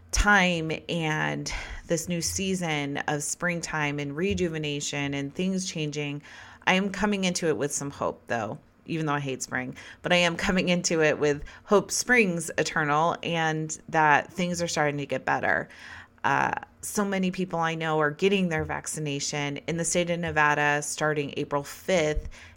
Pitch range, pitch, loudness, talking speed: 145-175 Hz, 155 Hz, -26 LUFS, 165 wpm